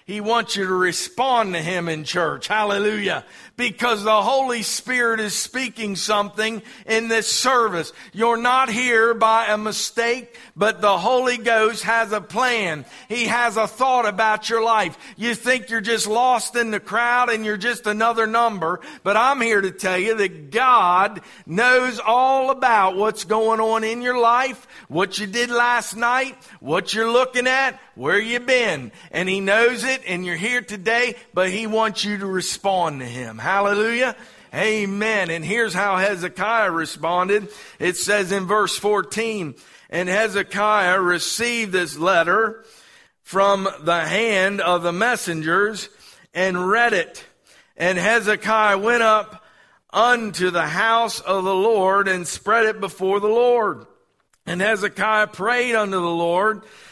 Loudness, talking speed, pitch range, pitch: -20 LUFS, 155 wpm, 195-235 Hz, 215 Hz